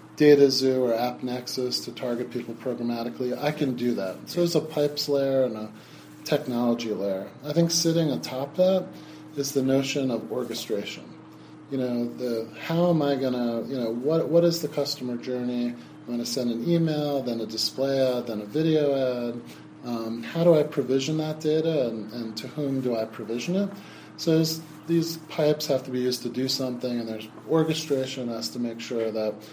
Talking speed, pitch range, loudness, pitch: 195 wpm, 120-150 Hz, -26 LUFS, 130 Hz